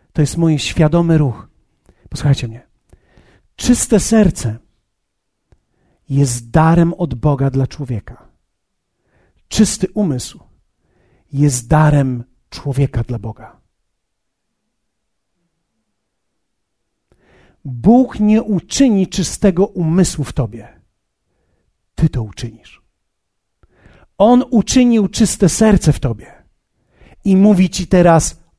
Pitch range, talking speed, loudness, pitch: 120-185 Hz, 90 wpm, -14 LUFS, 145 Hz